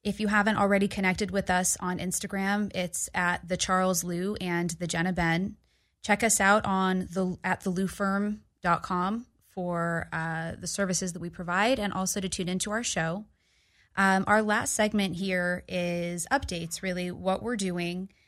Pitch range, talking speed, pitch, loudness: 180-200 Hz, 165 wpm, 185 Hz, -28 LUFS